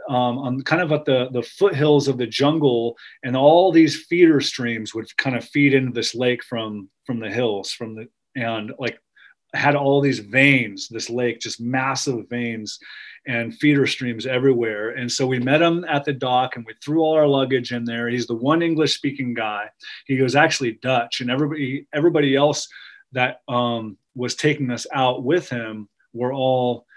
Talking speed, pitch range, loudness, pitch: 185 wpm, 120-145 Hz, -20 LUFS, 130 Hz